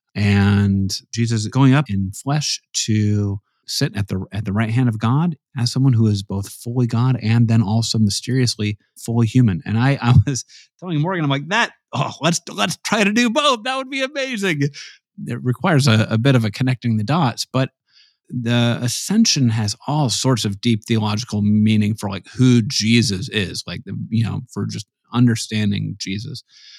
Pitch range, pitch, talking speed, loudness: 105-135 Hz, 120 Hz, 185 wpm, -19 LUFS